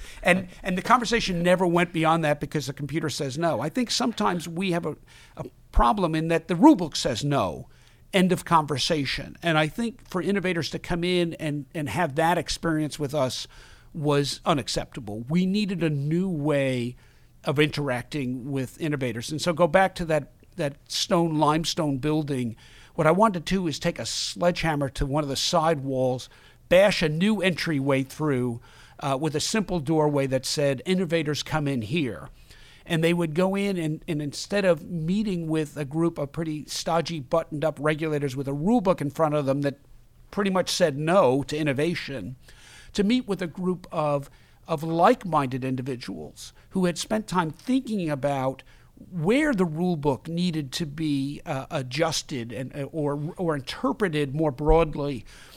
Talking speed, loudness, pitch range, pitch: 175 wpm, -25 LUFS, 140-175 Hz, 155 Hz